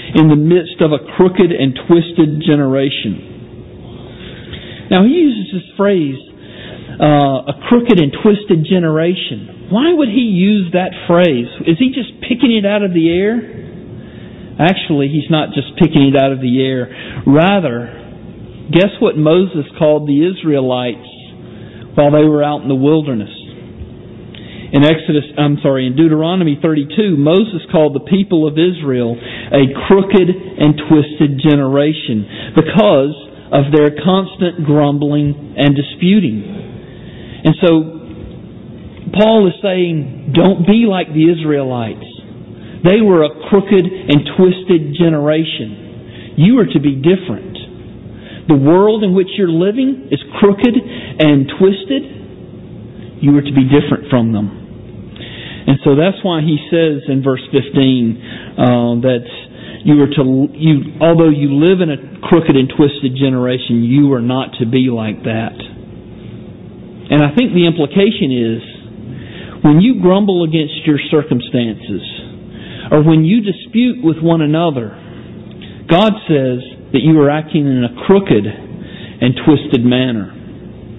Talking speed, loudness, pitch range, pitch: 135 wpm, -12 LUFS, 135-180 Hz, 150 Hz